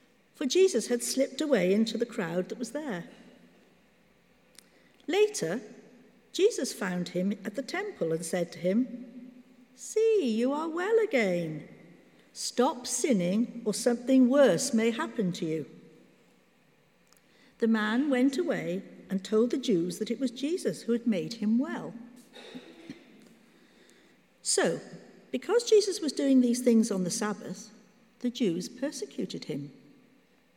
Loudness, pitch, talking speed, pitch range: -29 LUFS, 240 Hz, 130 wpm, 215-270 Hz